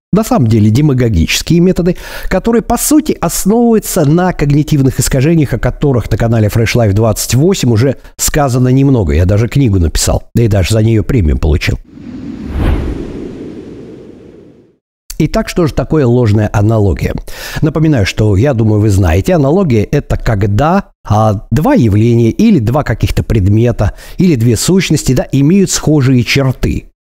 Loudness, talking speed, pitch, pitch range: -11 LUFS, 140 wpm, 130 Hz, 110-160 Hz